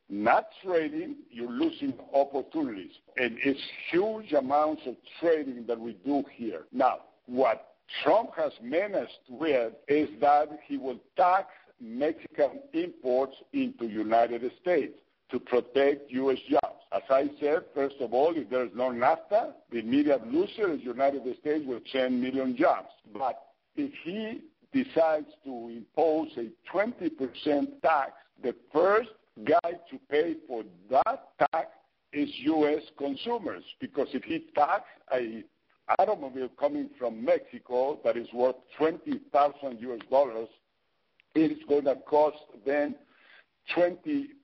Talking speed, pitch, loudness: 130 wpm, 150 Hz, -29 LUFS